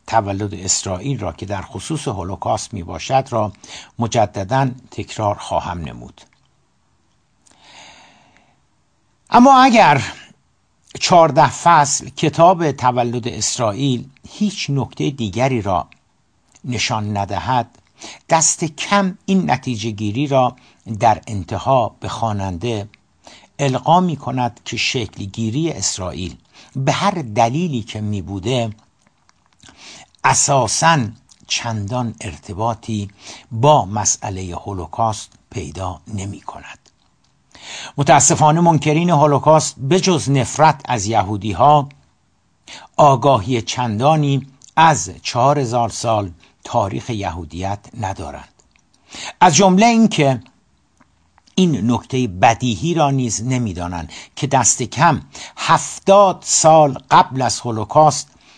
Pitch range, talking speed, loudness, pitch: 105-145 Hz, 100 wpm, -16 LUFS, 125 Hz